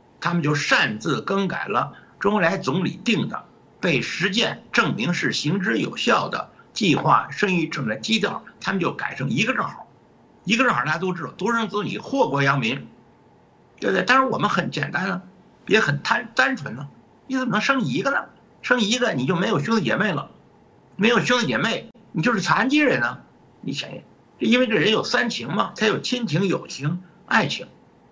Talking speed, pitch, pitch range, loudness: 275 characters per minute, 195 Hz, 165-235 Hz, -22 LUFS